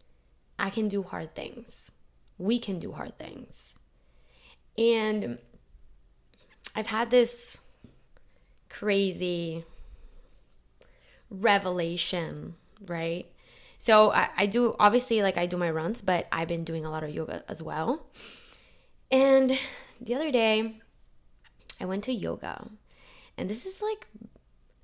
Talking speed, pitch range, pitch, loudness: 120 wpm, 160-230 Hz, 190 Hz, -28 LUFS